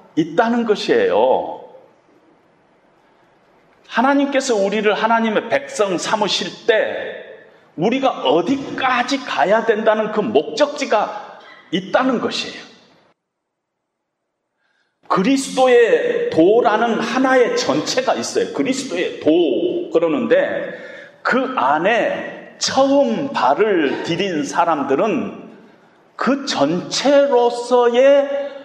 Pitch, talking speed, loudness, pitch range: 270 Hz, 200 characters per minute, -17 LUFS, 240-385 Hz